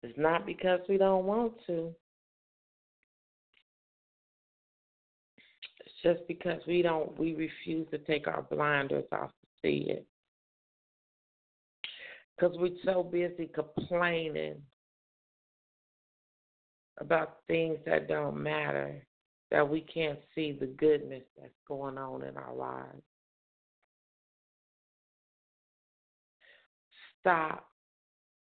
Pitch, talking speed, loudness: 155 Hz, 95 wpm, -33 LUFS